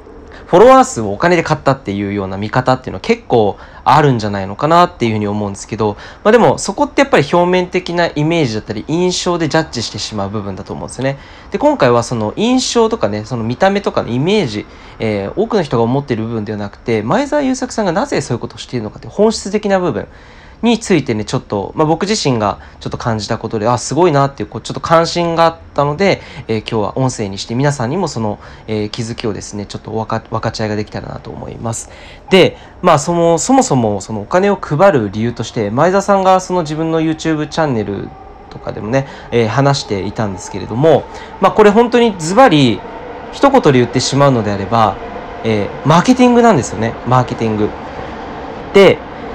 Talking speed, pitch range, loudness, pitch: 460 characters per minute, 110-175 Hz, -14 LUFS, 130 Hz